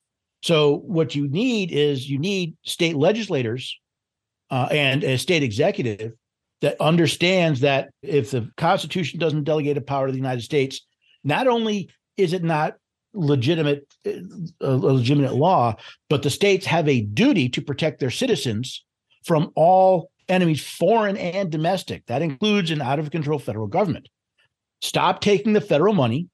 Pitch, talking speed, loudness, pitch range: 150 Hz, 155 wpm, -21 LUFS, 135-180 Hz